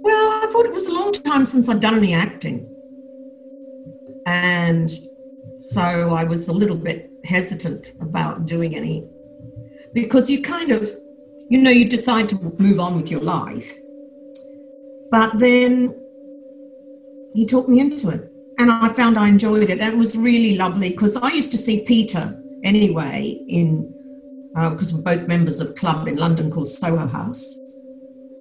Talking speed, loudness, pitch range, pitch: 165 wpm, -18 LUFS, 175-270 Hz, 235 Hz